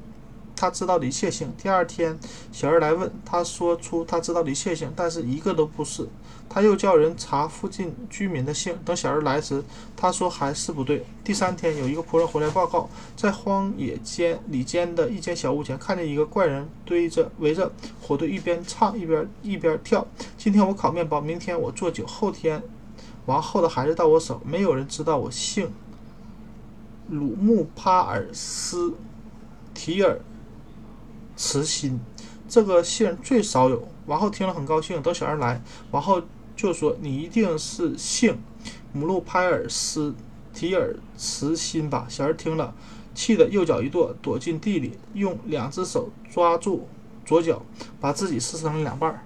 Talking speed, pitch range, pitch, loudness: 245 characters per minute, 145-185 Hz, 165 Hz, -24 LUFS